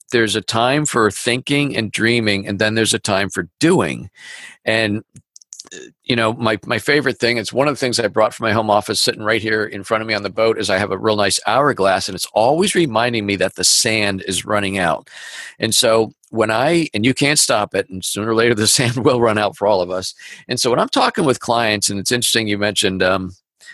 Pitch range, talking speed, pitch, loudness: 100-120 Hz, 240 wpm, 110 Hz, -17 LUFS